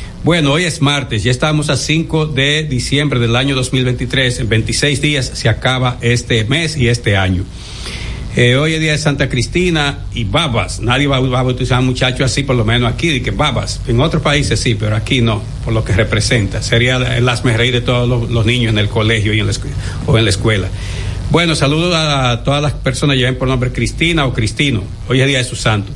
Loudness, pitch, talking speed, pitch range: -14 LUFS, 125 Hz, 225 wpm, 115-140 Hz